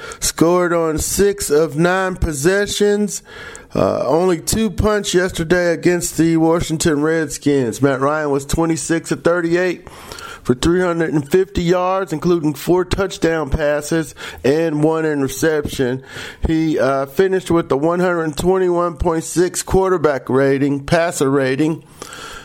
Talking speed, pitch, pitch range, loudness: 130 wpm, 165 Hz, 150-180 Hz, -17 LUFS